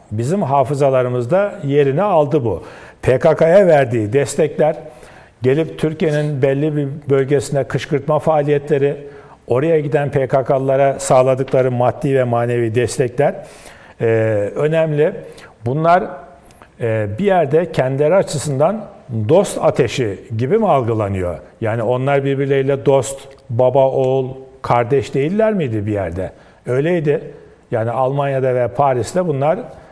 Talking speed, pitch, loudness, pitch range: 105 wpm, 140 Hz, -16 LUFS, 125-150 Hz